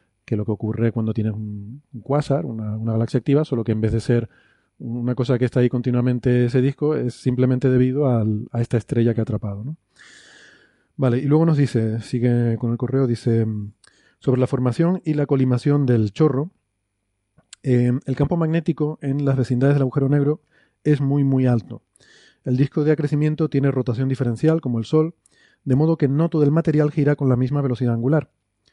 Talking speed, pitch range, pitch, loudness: 190 wpm, 115-145 Hz, 130 Hz, -21 LUFS